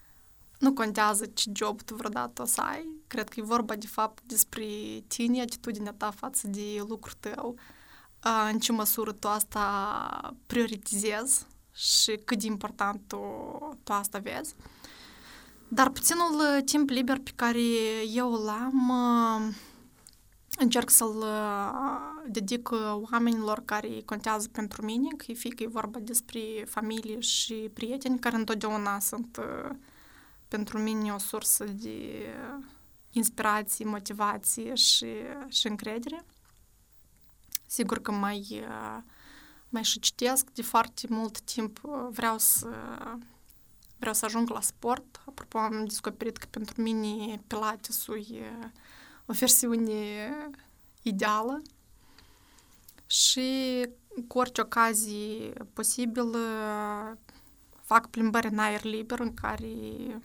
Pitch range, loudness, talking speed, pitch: 215-245 Hz, -29 LUFS, 120 wpm, 225 Hz